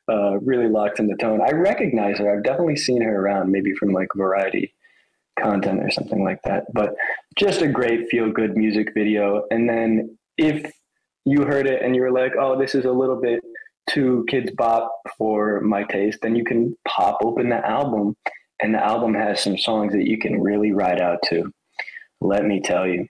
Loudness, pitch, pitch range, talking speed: -21 LUFS, 110 Hz, 100-125 Hz, 200 wpm